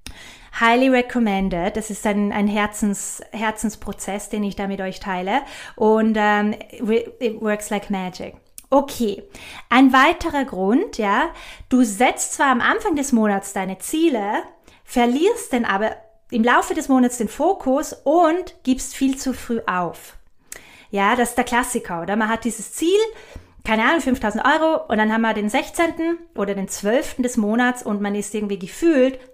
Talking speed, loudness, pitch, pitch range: 160 wpm, -20 LUFS, 230 Hz, 210-270 Hz